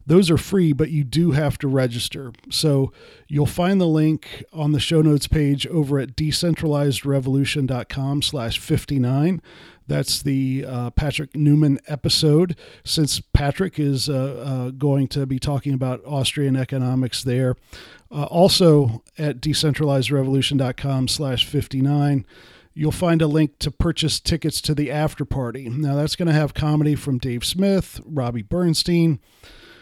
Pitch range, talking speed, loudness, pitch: 130-155 Hz, 145 wpm, -21 LUFS, 145 Hz